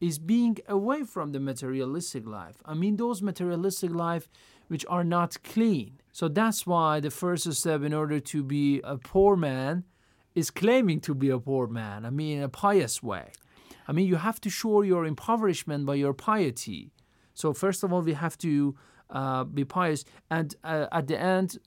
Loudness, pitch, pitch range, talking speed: -28 LUFS, 160 Hz, 140-185 Hz, 190 wpm